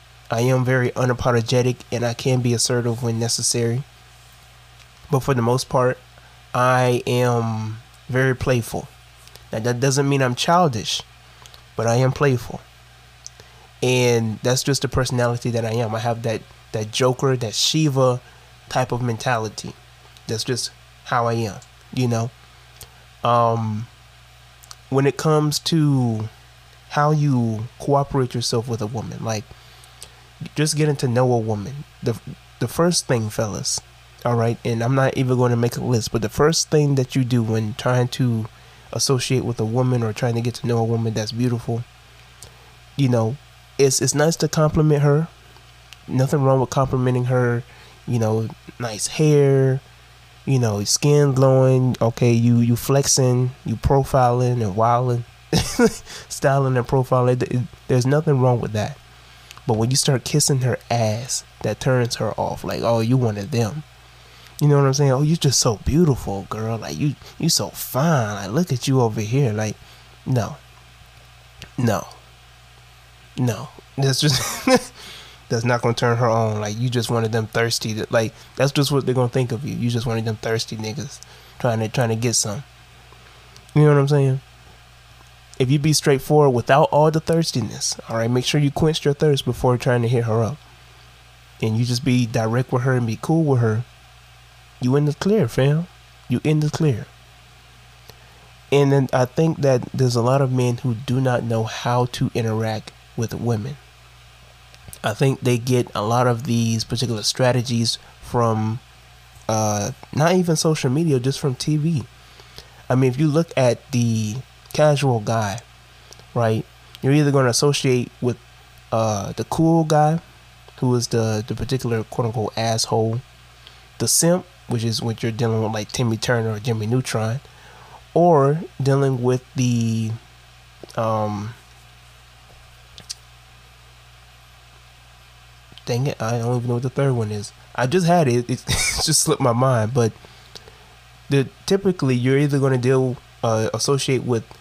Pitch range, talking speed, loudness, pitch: 110-135 Hz, 165 wpm, -20 LUFS, 120 Hz